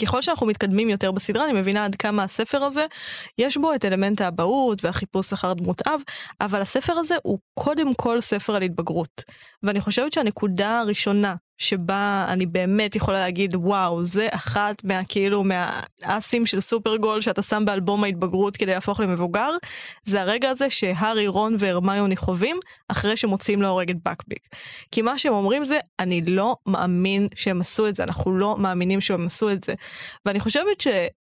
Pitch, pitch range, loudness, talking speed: 205 Hz, 190-225 Hz, -23 LUFS, 160 wpm